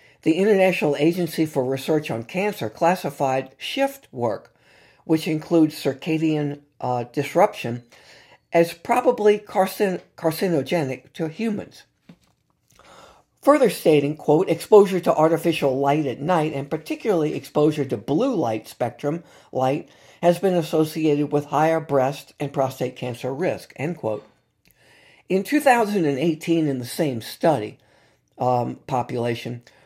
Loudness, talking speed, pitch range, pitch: -22 LUFS, 115 wpm, 135-175 Hz, 155 Hz